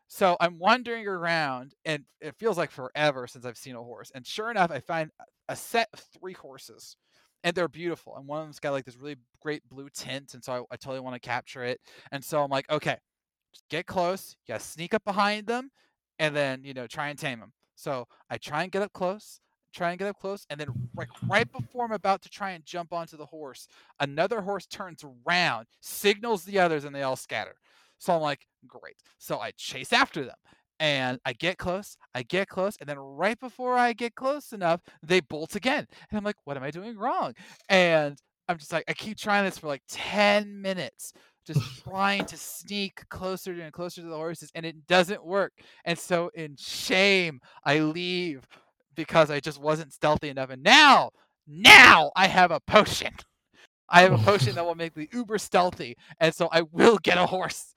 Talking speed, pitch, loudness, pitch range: 210 wpm, 165 Hz, -24 LUFS, 145-195 Hz